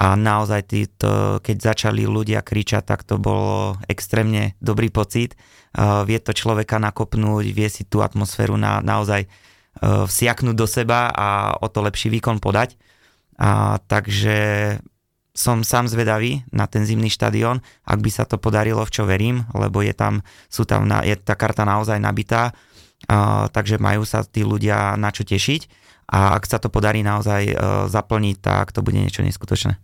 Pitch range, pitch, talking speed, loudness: 105-115 Hz, 110 Hz, 170 wpm, -20 LUFS